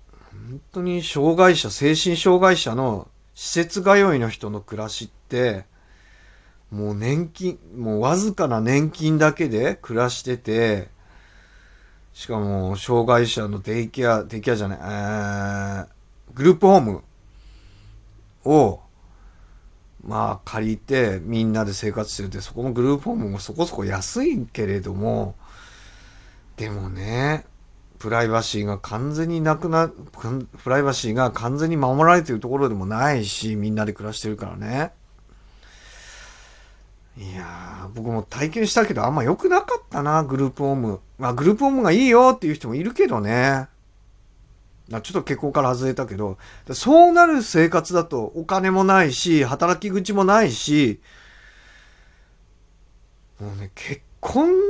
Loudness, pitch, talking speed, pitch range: -21 LUFS, 115 Hz, 275 characters per minute, 100-155 Hz